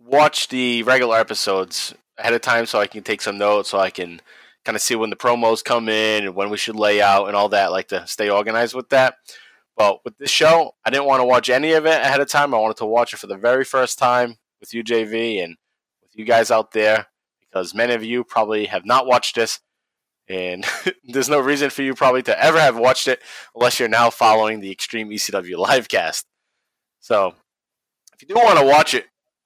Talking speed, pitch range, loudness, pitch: 225 wpm, 105-130 Hz, -18 LUFS, 115 Hz